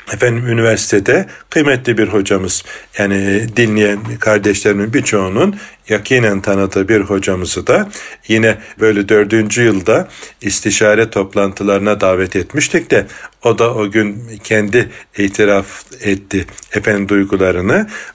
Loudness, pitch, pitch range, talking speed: -13 LUFS, 105 Hz, 100-110 Hz, 105 wpm